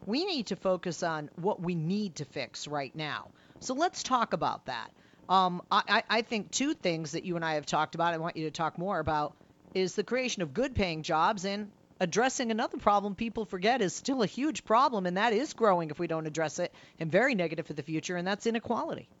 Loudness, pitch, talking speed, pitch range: -31 LUFS, 185 Hz, 230 wpm, 165-225 Hz